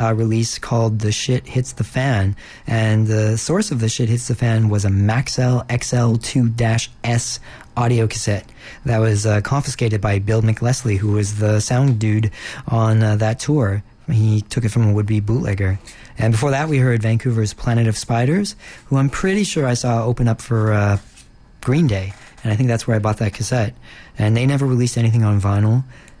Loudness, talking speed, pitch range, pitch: -18 LUFS, 190 wpm, 110-125 Hz, 115 Hz